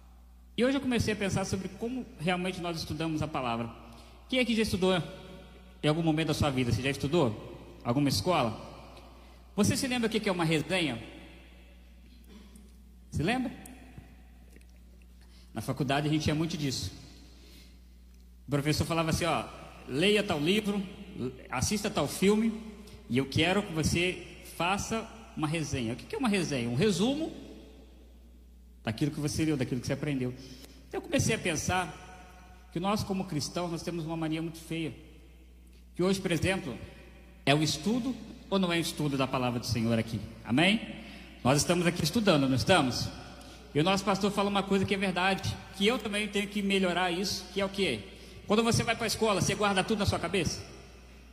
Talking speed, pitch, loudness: 180 wpm, 160 Hz, -30 LUFS